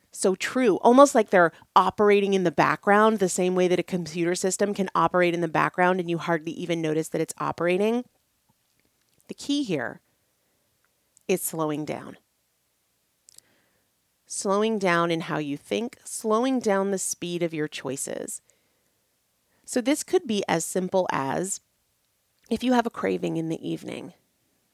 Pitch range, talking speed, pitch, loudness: 165-210 Hz, 155 wpm, 180 Hz, -24 LUFS